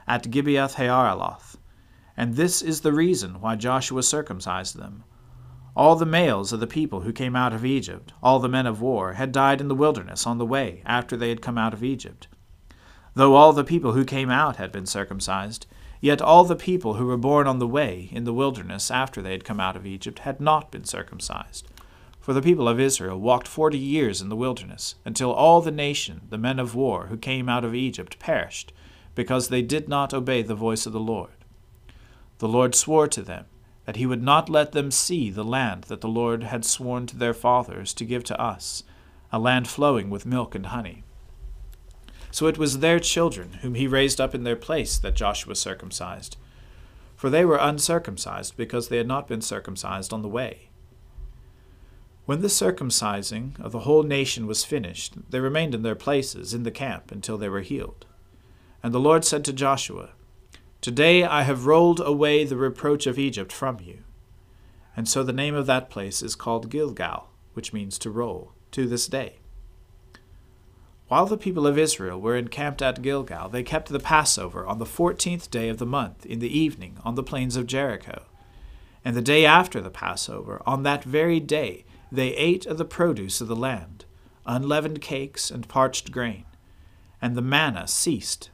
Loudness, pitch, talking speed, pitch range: -23 LUFS, 125 Hz, 190 wpm, 100-140 Hz